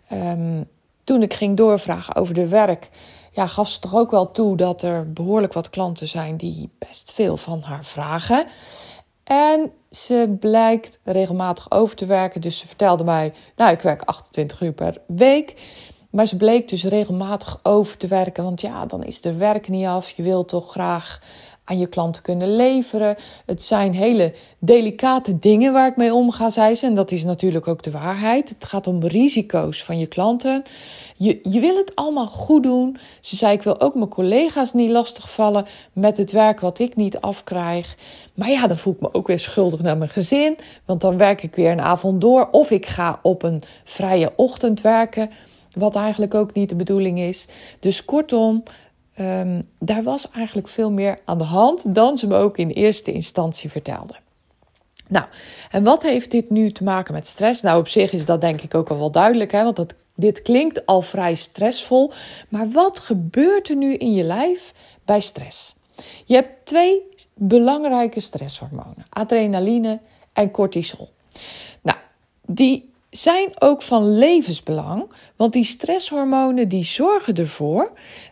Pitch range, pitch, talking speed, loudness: 175-235 Hz, 205 Hz, 175 wpm, -19 LUFS